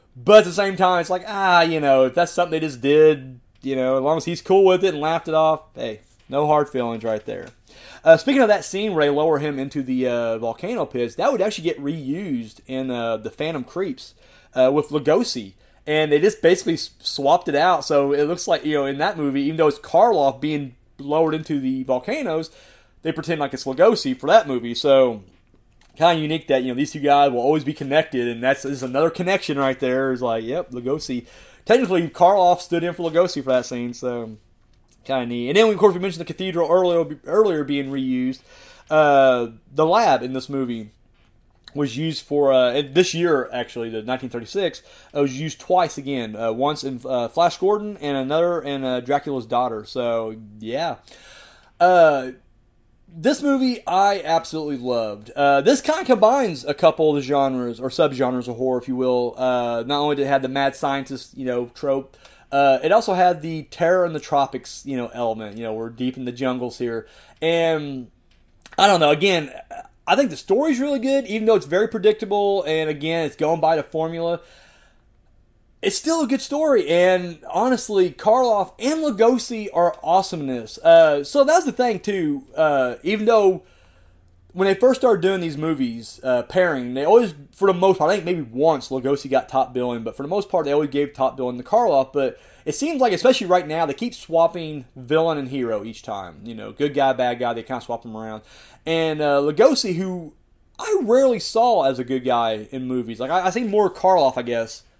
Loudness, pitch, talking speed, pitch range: -20 LUFS, 145 Hz, 205 wpm, 125-180 Hz